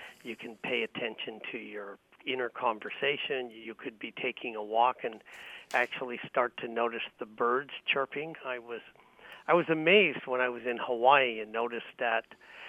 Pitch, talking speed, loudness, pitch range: 125 Hz, 165 wpm, -31 LUFS, 115-145 Hz